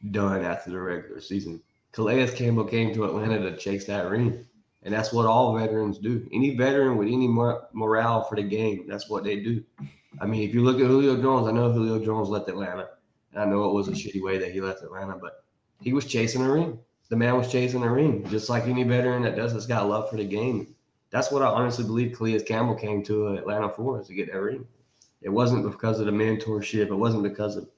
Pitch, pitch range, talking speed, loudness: 110 Hz, 105-120 Hz, 235 wpm, -26 LUFS